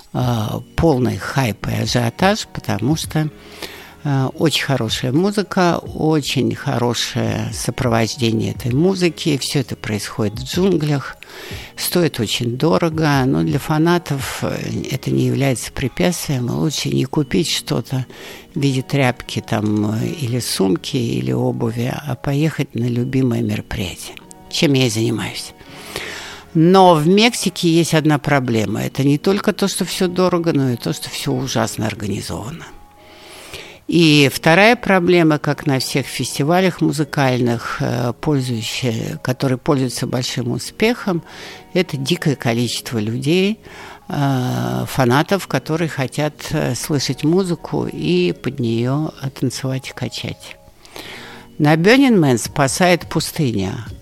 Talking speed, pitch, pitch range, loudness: 115 wpm, 135 Hz, 120-160 Hz, -18 LUFS